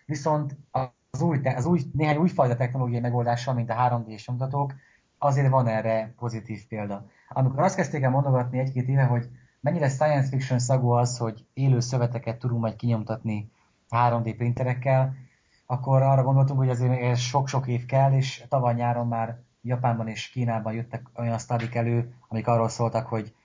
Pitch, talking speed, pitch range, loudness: 125 Hz, 160 wpm, 115-135 Hz, -25 LUFS